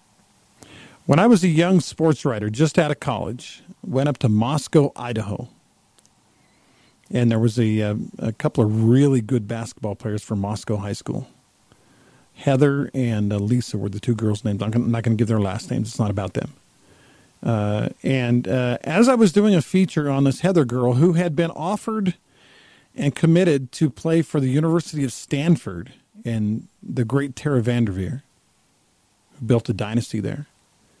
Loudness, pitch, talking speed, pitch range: -21 LUFS, 125 Hz, 170 wpm, 110-150 Hz